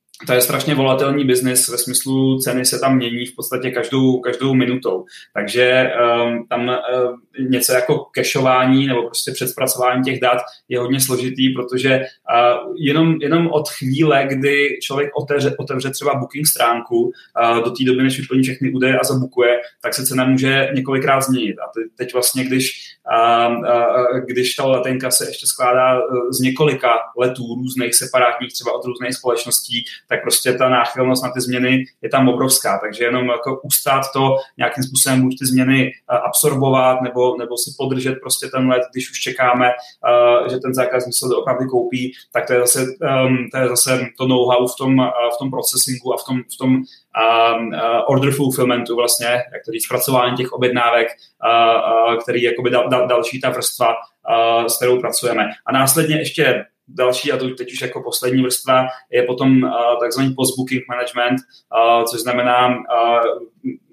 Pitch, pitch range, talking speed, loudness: 125 Hz, 125-130 Hz, 170 wpm, -17 LUFS